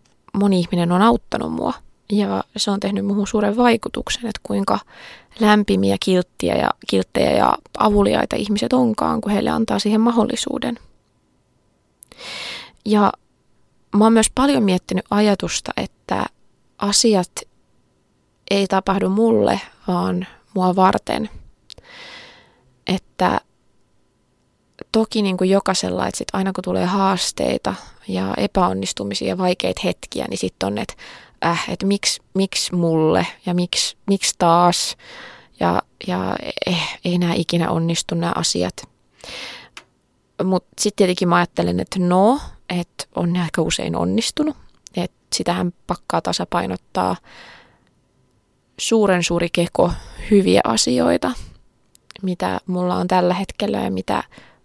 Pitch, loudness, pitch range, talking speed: 185 Hz, -19 LUFS, 170-210 Hz, 120 wpm